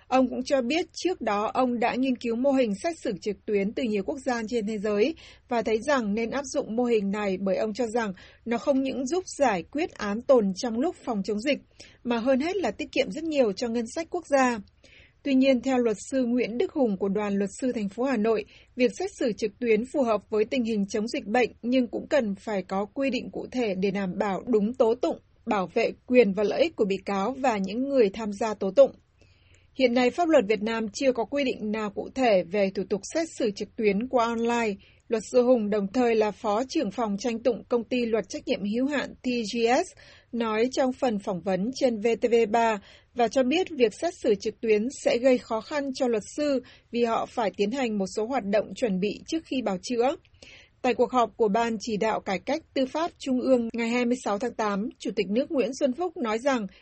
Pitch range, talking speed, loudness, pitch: 215-265 Hz, 240 wpm, -26 LUFS, 240 Hz